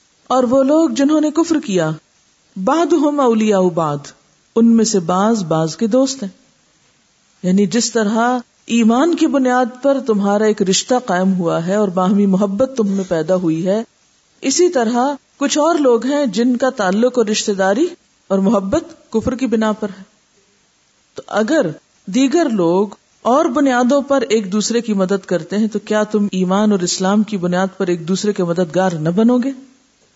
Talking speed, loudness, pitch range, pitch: 175 wpm, -16 LUFS, 195-260 Hz, 220 Hz